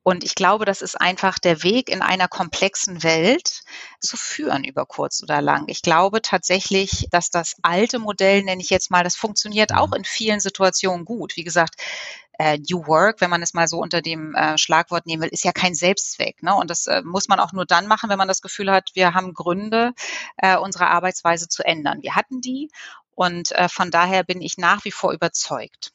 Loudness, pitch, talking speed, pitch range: -20 LUFS, 185 Hz, 200 wpm, 175-195 Hz